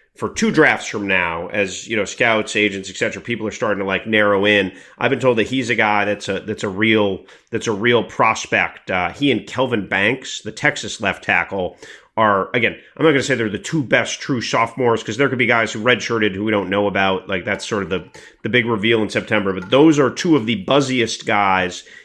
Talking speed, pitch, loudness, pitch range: 235 wpm, 110 Hz, -18 LUFS, 105-125 Hz